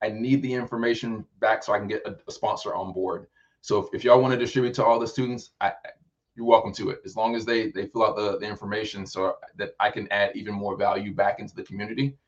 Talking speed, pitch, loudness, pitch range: 255 wpm, 115 Hz, -26 LUFS, 105-120 Hz